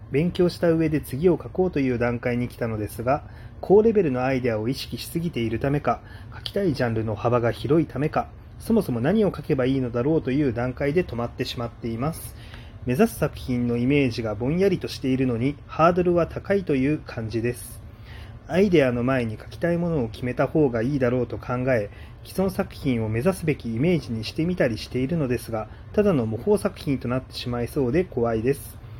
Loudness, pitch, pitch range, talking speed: -24 LUFS, 125 Hz, 115-155 Hz, 420 characters per minute